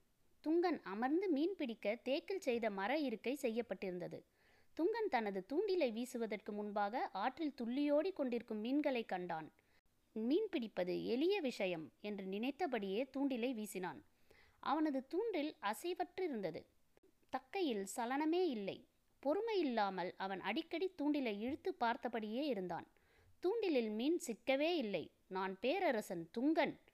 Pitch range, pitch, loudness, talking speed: 215-320 Hz, 255 Hz, -40 LUFS, 105 wpm